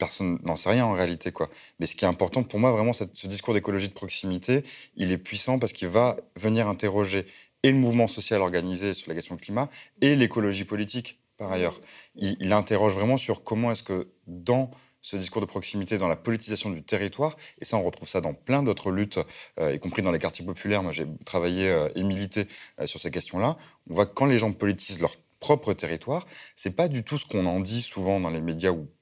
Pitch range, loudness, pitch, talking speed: 95-120 Hz, -27 LUFS, 105 Hz, 220 wpm